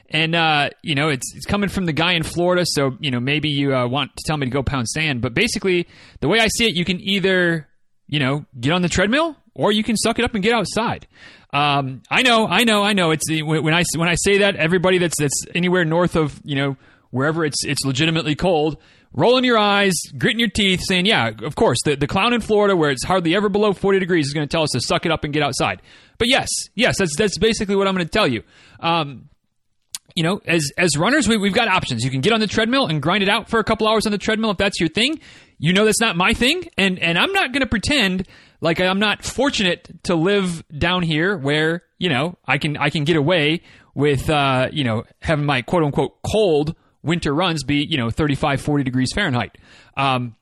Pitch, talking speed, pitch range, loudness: 170 Hz, 245 wpm, 145-200 Hz, -18 LUFS